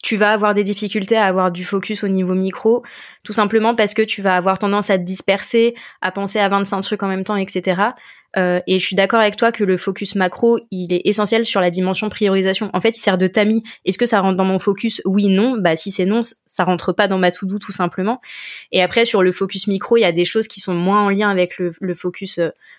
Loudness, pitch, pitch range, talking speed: -17 LUFS, 200 Hz, 185-215 Hz, 260 wpm